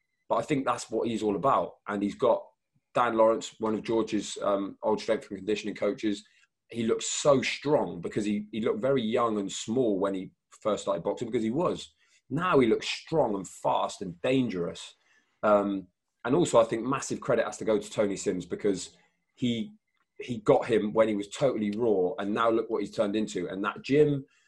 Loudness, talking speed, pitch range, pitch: -28 LUFS, 205 wpm, 105-120 Hz, 110 Hz